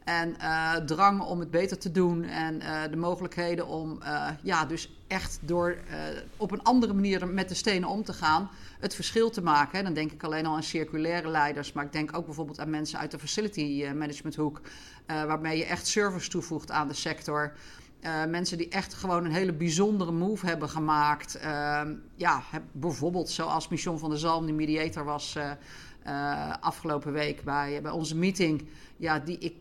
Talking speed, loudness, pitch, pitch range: 195 wpm, -30 LUFS, 160 Hz, 150-175 Hz